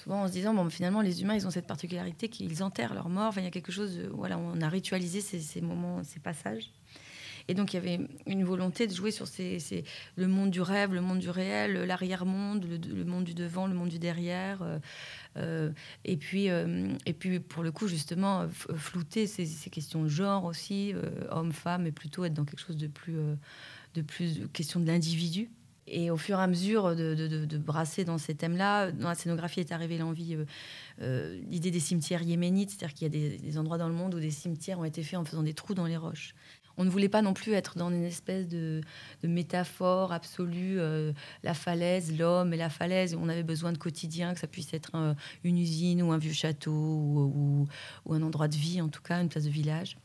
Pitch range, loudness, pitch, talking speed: 155-185 Hz, -33 LUFS, 170 Hz, 235 wpm